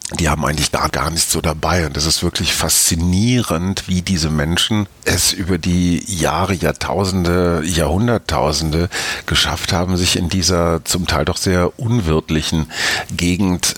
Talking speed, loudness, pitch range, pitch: 150 wpm, -16 LUFS, 80-95 Hz, 85 Hz